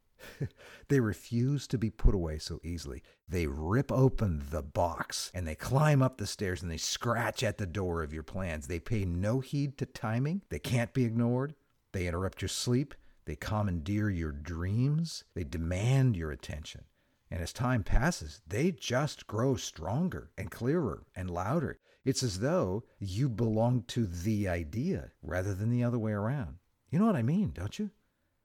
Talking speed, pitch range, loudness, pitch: 175 wpm, 85-130 Hz, -33 LUFS, 105 Hz